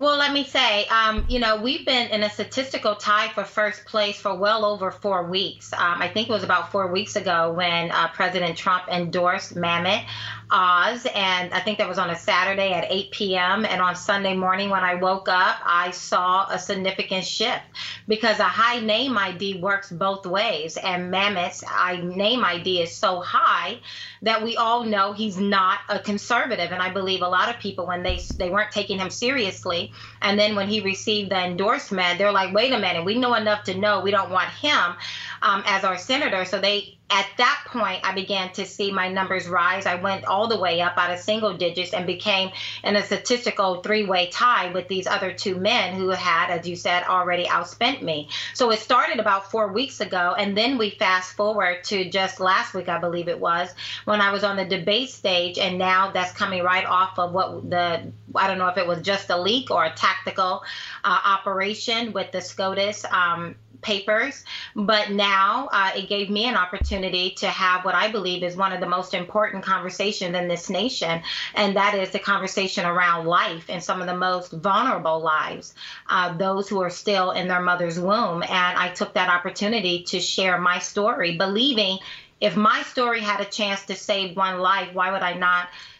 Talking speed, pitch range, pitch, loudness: 205 wpm, 180-205 Hz, 190 Hz, -22 LUFS